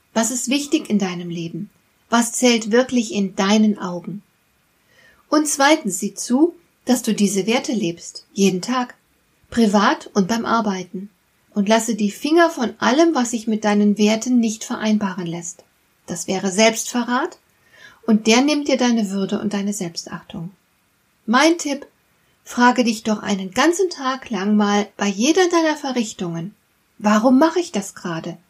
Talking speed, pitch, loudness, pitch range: 150 wpm, 220 Hz, -19 LUFS, 200-255 Hz